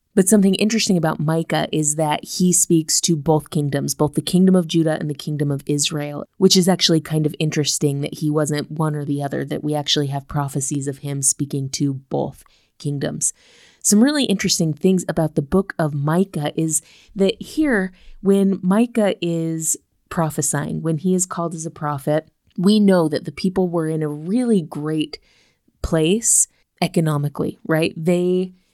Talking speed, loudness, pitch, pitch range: 175 wpm, -19 LUFS, 160 Hz, 150-185 Hz